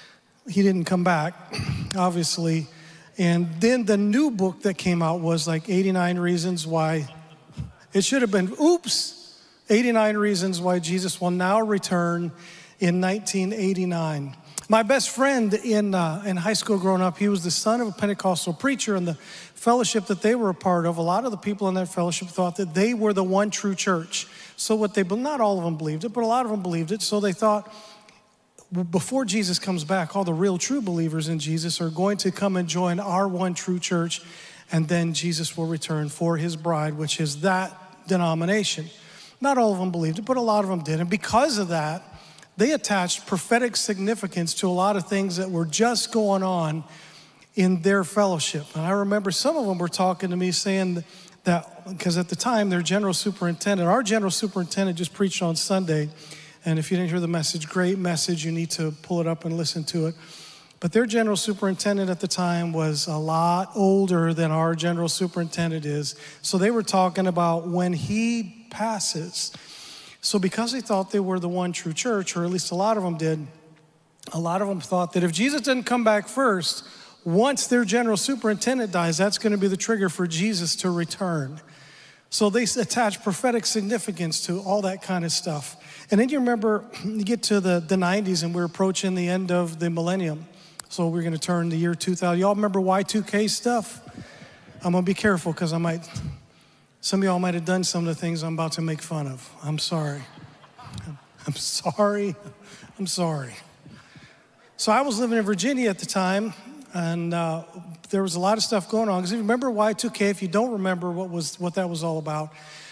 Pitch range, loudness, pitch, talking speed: 170-205 Hz, -24 LUFS, 185 Hz, 200 wpm